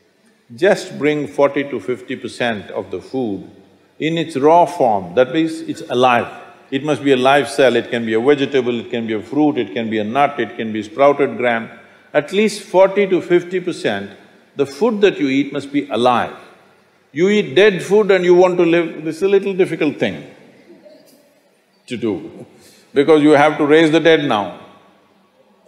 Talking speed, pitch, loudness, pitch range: 190 wpm, 150 Hz, -16 LUFS, 130-180 Hz